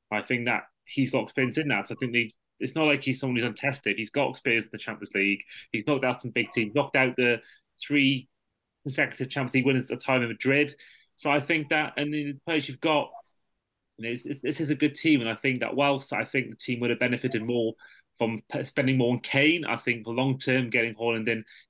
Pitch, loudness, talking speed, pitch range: 130 Hz, -27 LUFS, 240 wpm, 120-145 Hz